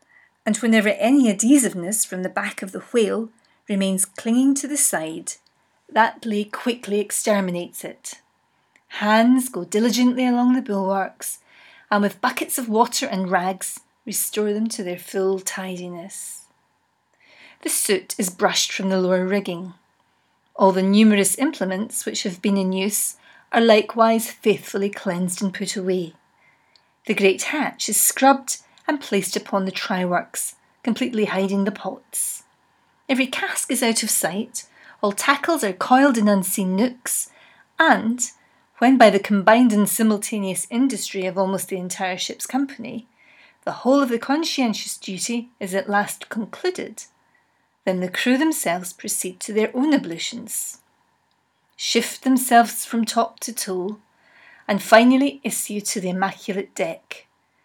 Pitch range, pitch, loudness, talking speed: 195-250 Hz, 215 Hz, -21 LUFS, 140 wpm